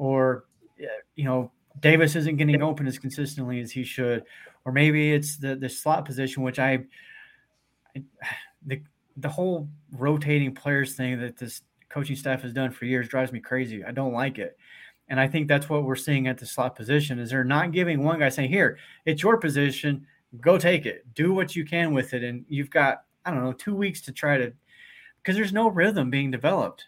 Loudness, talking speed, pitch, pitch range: -25 LUFS, 205 wpm, 140 Hz, 130-155 Hz